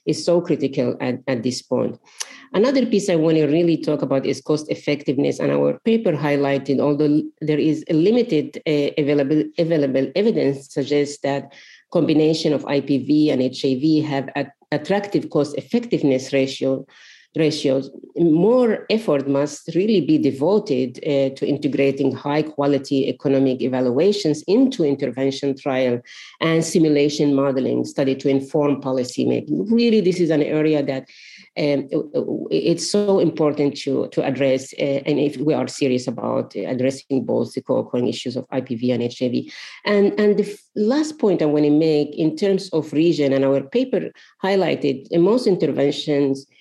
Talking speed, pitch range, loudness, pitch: 155 wpm, 135-165 Hz, -20 LUFS, 145 Hz